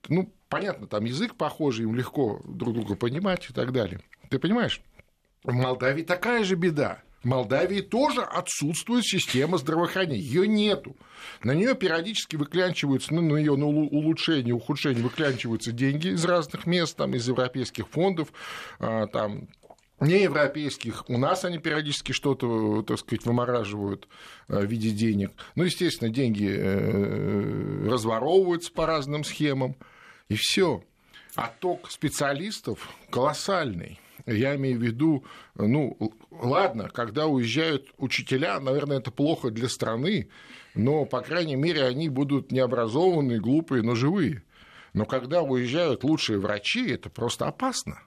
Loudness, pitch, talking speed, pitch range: -26 LUFS, 140 Hz, 130 wpm, 120-170 Hz